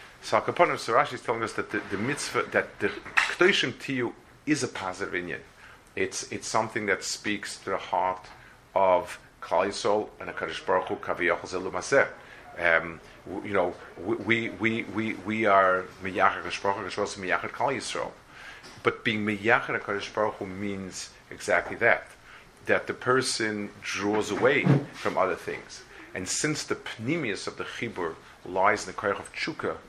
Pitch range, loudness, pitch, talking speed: 95-115 Hz, -27 LUFS, 105 Hz, 150 wpm